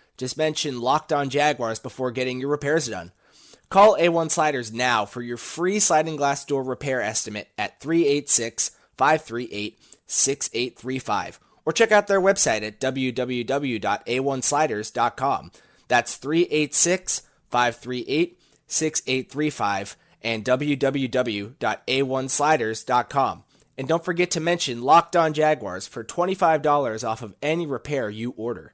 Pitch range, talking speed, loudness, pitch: 120-155 Hz, 115 wpm, -22 LUFS, 135 Hz